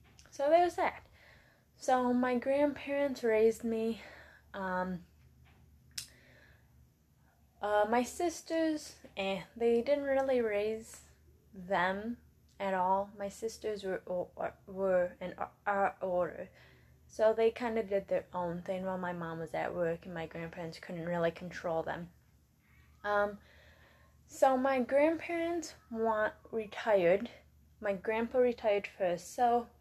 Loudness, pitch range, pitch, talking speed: -34 LUFS, 180-245 Hz, 205 Hz, 125 wpm